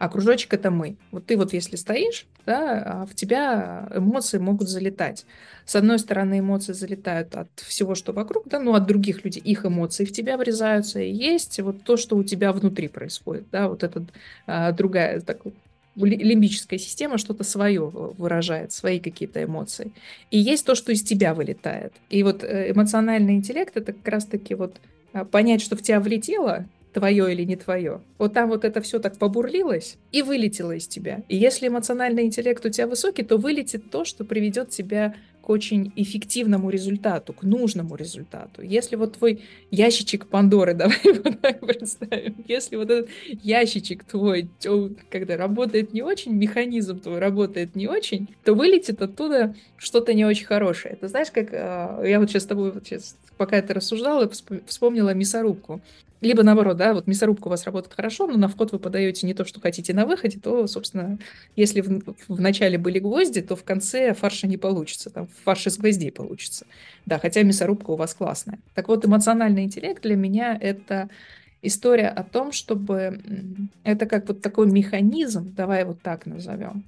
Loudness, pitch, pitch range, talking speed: -23 LUFS, 205 Hz, 195-225 Hz, 175 wpm